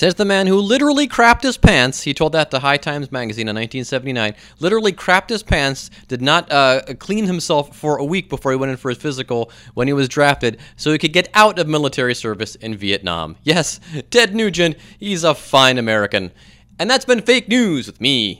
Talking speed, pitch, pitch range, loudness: 210 wpm, 140 Hz, 125-185 Hz, -16 LUFS